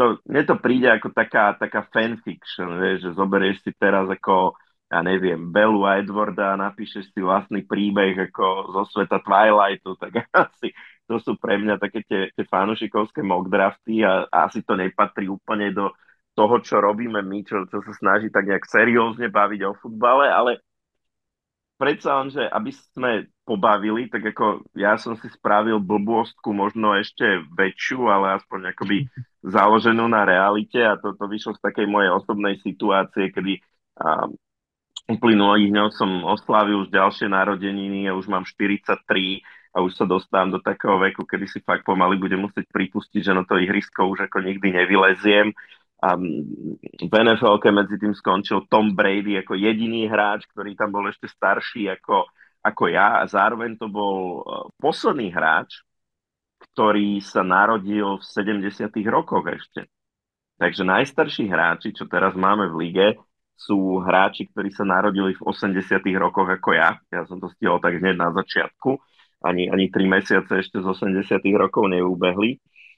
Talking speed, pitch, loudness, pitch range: 160 wpm, 100 Hz, -21 LUFS, 95-105 Hz